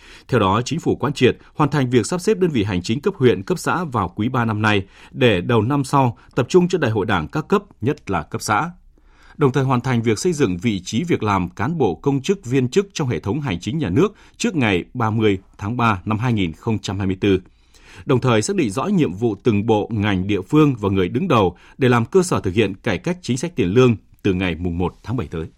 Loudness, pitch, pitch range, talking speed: -19 LUFS, 115 Hz, 100-140 Hz, 245 wpm